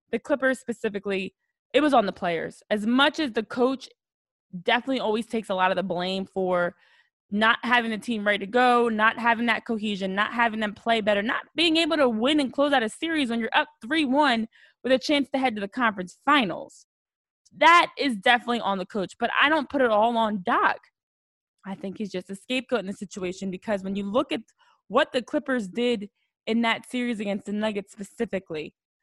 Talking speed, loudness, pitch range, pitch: 210 wpm, -24 LUFS, 205-265 Hz, 230 Hz